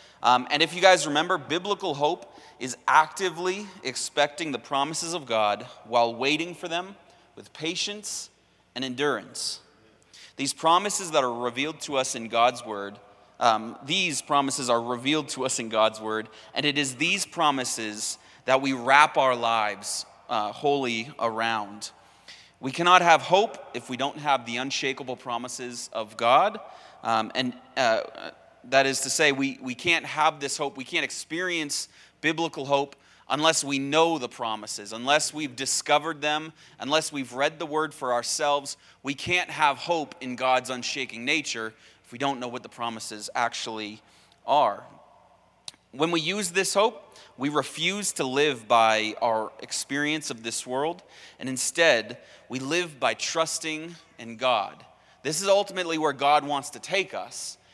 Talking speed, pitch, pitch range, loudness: 160 wpm, 140 Hz, 120-160 Hz, -25 LUFS